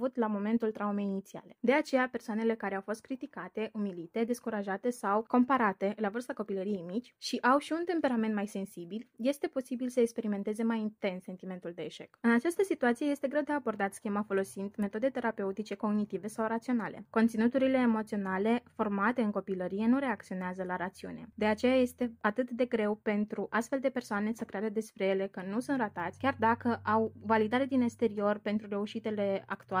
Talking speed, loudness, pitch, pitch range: 170 wpm, -32 LUFS, 220 Hz, 200-245 Hz